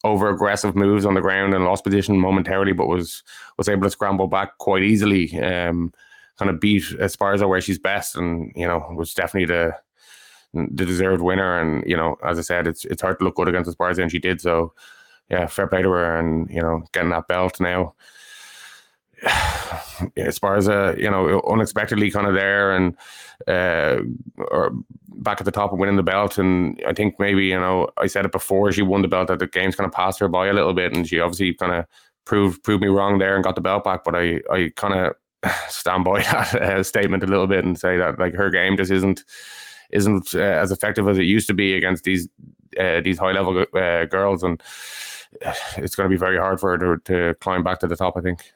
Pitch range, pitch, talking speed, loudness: 90-100 Hz, 95 Hz, 225 wpm, -20 LUFS